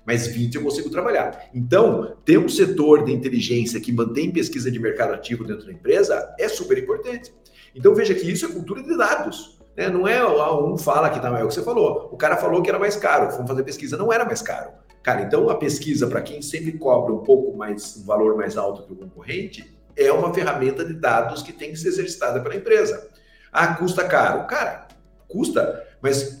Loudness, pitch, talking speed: -21 LUFS, 190 Hz, 210 wpm